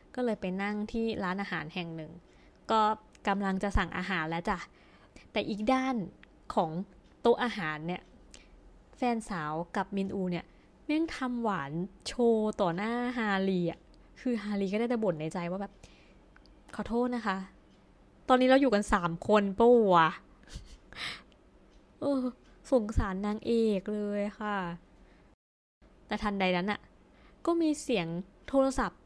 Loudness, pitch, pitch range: -31 LUFS, 205 Hz, 185-235 Hz